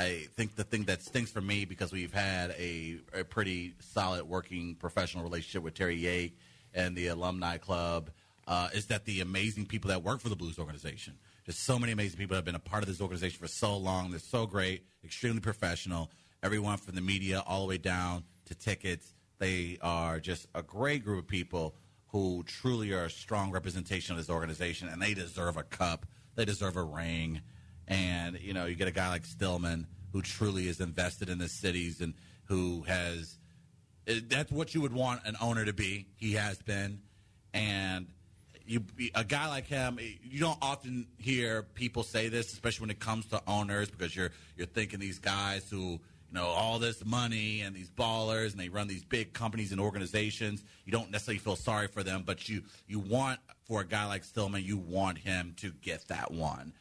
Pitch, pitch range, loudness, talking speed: 95 Hz, 90-110 Hz, -35 LUFS, 200 wpm